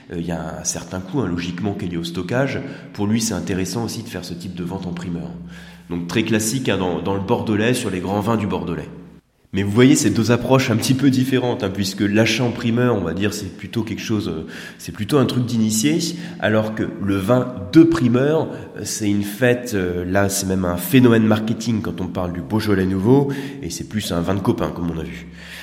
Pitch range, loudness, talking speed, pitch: 90-120 Hz, -20 LUFS, 235 wpm, 105 Hz